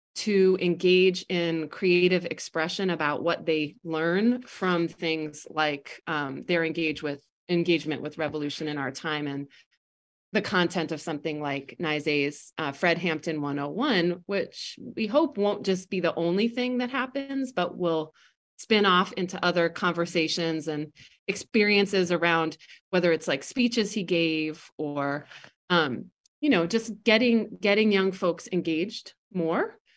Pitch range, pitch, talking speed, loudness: 155-200 Hz, 175 Hz, 140 wpm, -26 LUFS